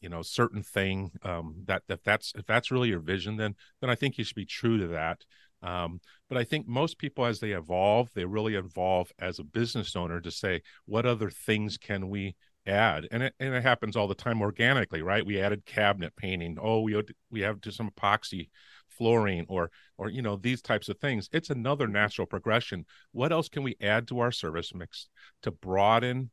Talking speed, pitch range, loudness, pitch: 210 wpm, 95-120 Hz, -30 LUFS, 105 Hz